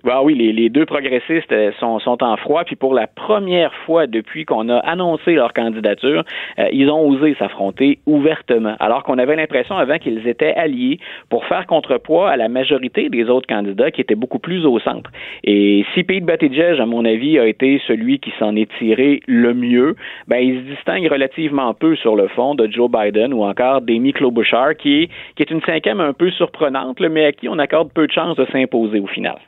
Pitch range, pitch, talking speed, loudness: 115-160 Hz, 135 Hz, 200 wpm, -16 LUFS